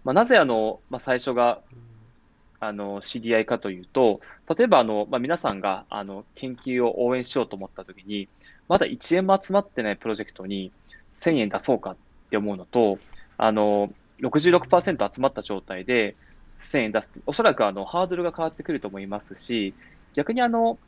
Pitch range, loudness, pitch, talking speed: 100-130 Hz, -24 LUFS, 115 Hz, 335 characters per minute